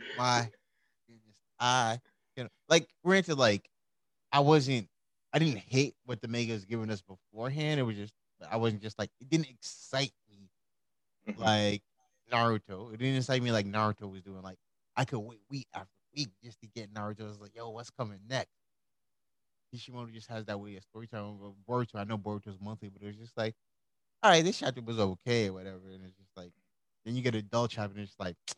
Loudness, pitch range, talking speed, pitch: -32 LUFS, 100-125 Hz, 205 wpm, 110 Hz